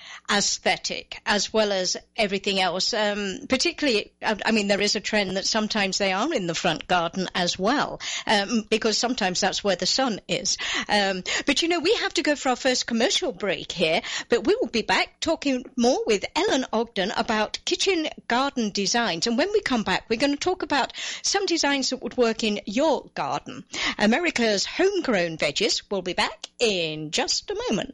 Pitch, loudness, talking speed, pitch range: 230 Hz, -24 LUFS, 190 wpm, 200-285 Hz